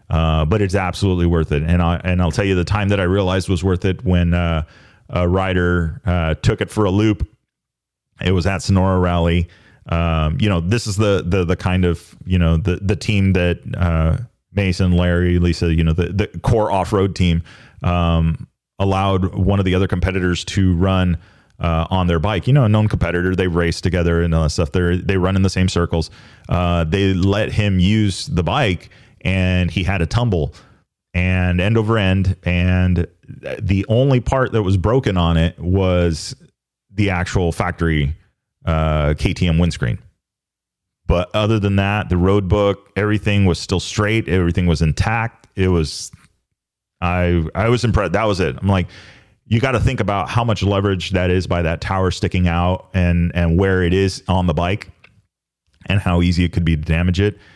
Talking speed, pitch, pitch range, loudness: 190 wpm, 95 Hz, 85-100 Hz, -18 LUFS